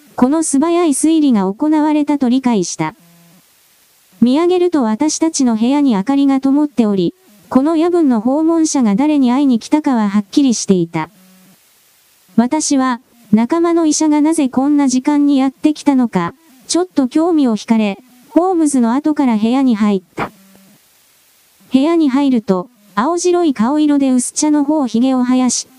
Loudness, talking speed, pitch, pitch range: -14 LUFS, 310 characters per minute, 265 Hz, 225-300 Hz